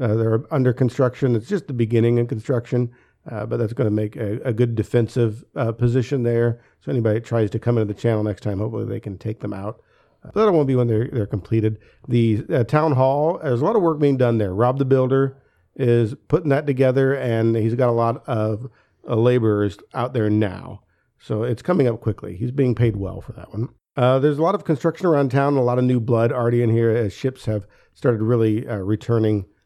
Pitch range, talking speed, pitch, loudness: 110-130 Hz, 230 wpm, 120 Hz, -21 LUFS